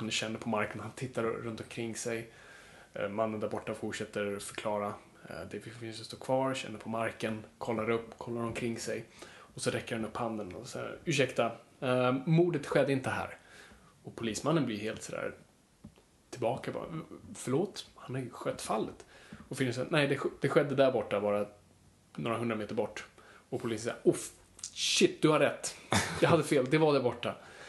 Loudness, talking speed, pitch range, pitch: -33 LUFS, 175 wpm, 110-125 Hz, 115 Hz